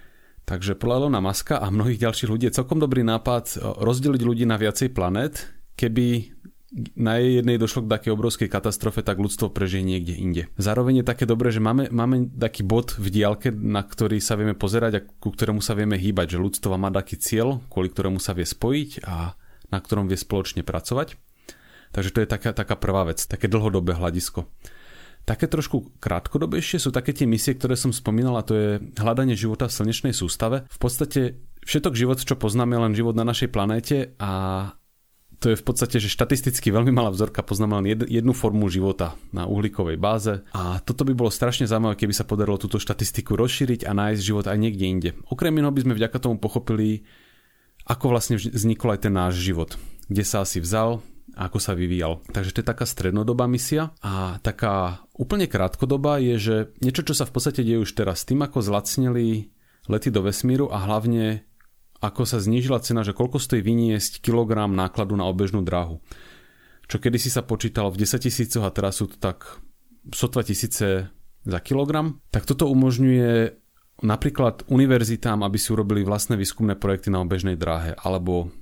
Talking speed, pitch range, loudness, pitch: 180 wpm, 100-125 Hz, -23 LUFS, 110 Hz